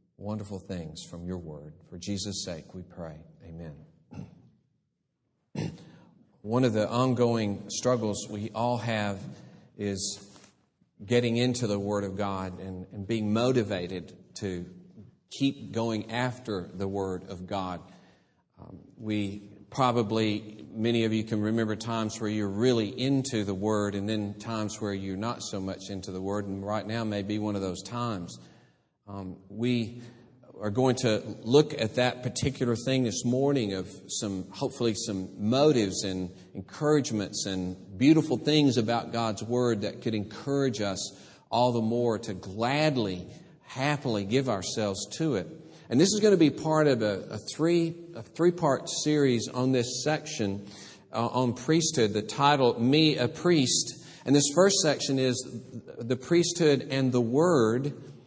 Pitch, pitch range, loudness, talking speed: 110 Hz, 100-125 Hz, -28 LUFS, 150 wpm